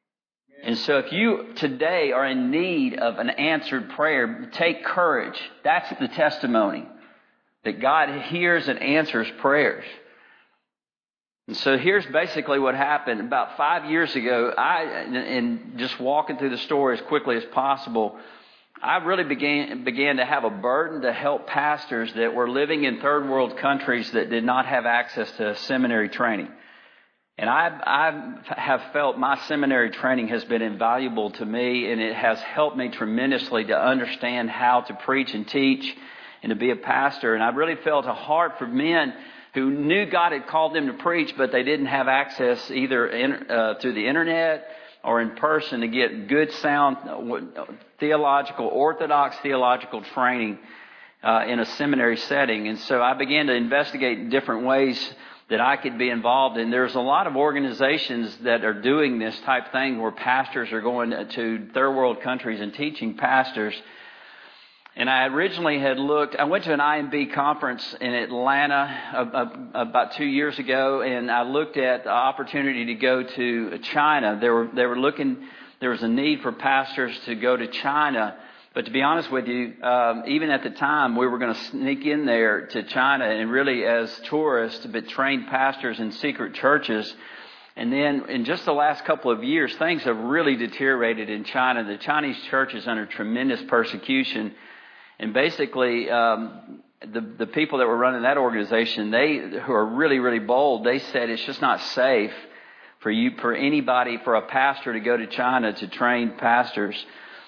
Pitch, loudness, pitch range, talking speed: 130 Hz, -23 LUFS, 120-145 Hz, 175 wpm